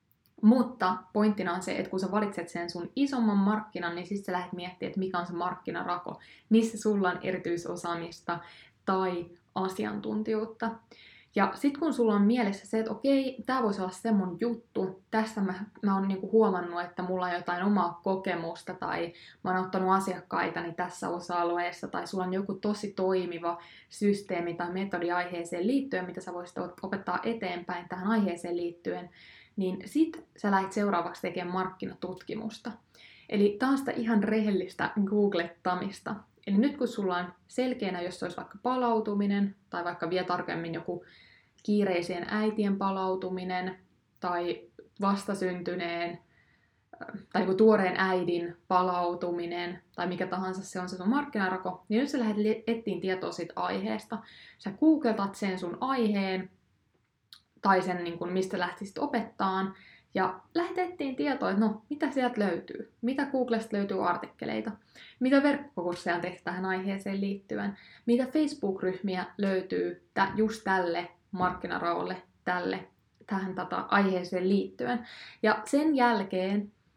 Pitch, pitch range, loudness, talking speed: 190 Hz, 180-215 Hz, -31 LUFS, 140 wpm